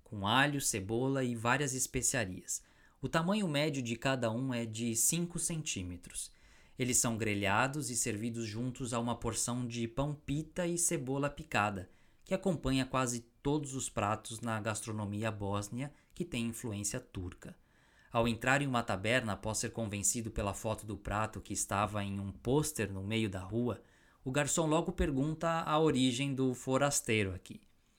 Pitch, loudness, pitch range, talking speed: 120 Hz, -34 LUFS, 110-135 Hz, 155 wpm